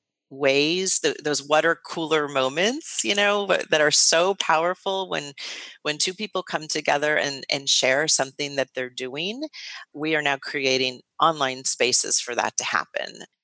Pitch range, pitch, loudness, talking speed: 135-175 Hz, 150 Hz, -22 LUFS, 160 wpm